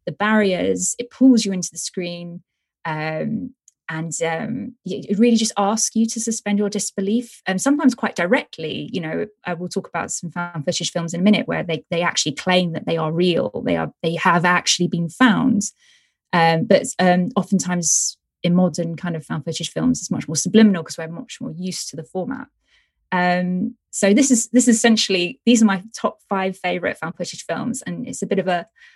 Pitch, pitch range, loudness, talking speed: 185 Hz, 175-225 Hz, -20 LUFS, 205 wpm